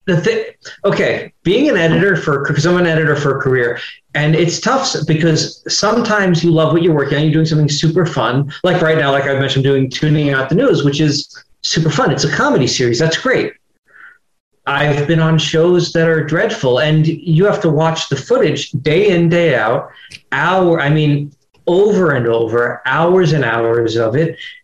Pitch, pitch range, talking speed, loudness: 155 Hz, 140-170 Hz, 195 wpm, -14 LUFS